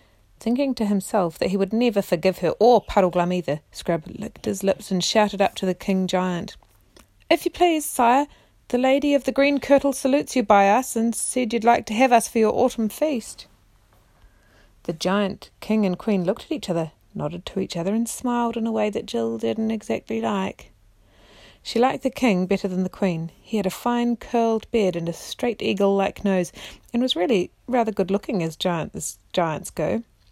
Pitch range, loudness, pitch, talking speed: 180-240 Hz, -22 LUFS, 205 Hz, 195 wpm